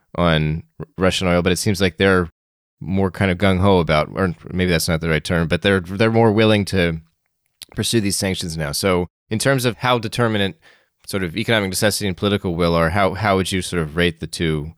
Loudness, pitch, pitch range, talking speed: -19 LUFS, 95 Hz, 85-100 Hz, 220 wpm